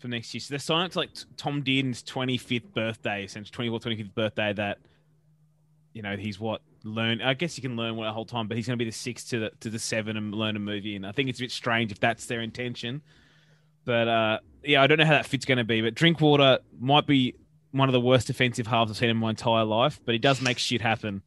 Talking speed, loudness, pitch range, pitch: 260 wpm, -26 LUFS, 110-135 Hz, 120 Hz